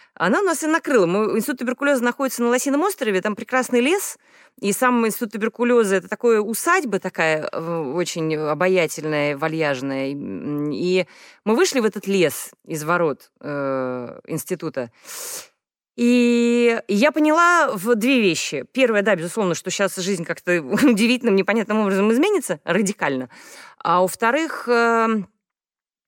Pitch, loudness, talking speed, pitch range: 215 Hz, -20 LUFS, 130 wpm, 175-250 Hz